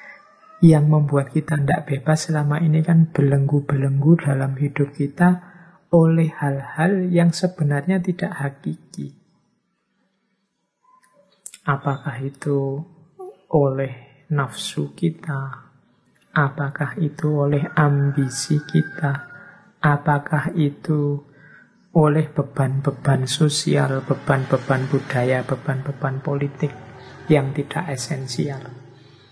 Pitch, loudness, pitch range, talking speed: 145 Hz, -21 LUFS, 140-165 Hz, 80 wpm